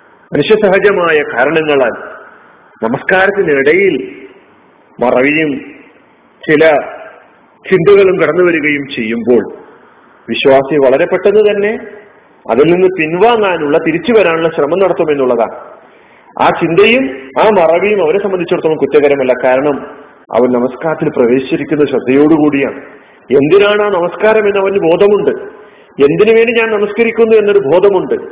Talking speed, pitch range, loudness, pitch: 95 wpm, 150-215 Hz, -10 LUFS, 185 Hz